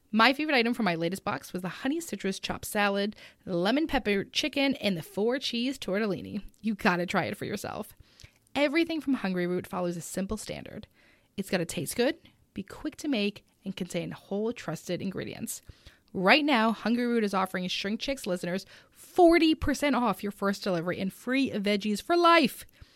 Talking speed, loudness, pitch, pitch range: 180 wpm, -28 LUFS, 205 Hz, 190-265 Hz